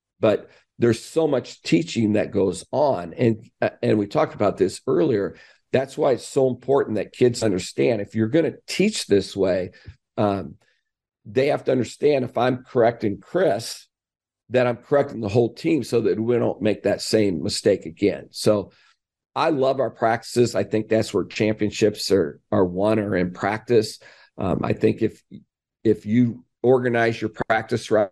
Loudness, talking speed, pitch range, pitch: -22 LUFS, 170 wpm, 105-125 Hz, 115 Hz